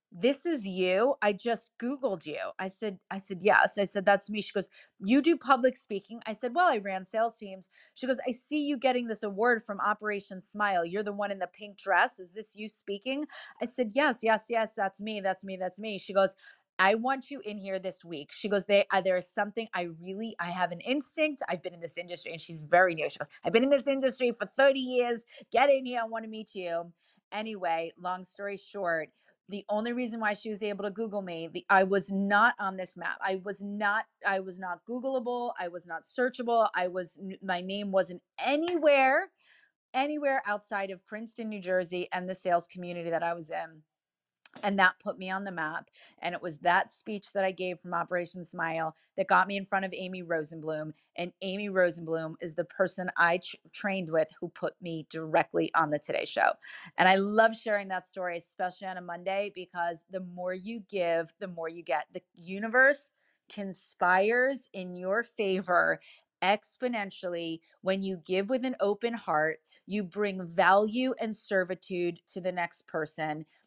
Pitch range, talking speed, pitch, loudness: 180-225 Hz, 205 wpm, 195 Hz, -30 LUFS